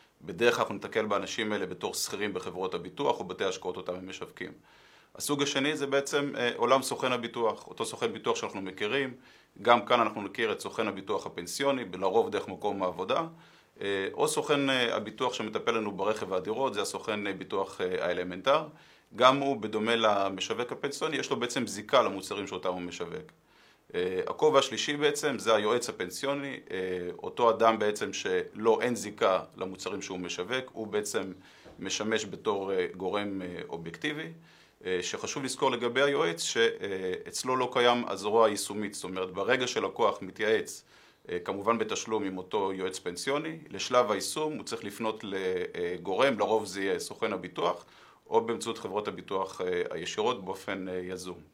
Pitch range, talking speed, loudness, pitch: 95-155 Hz, 140 wpm, -30 LUFS, 120 Hz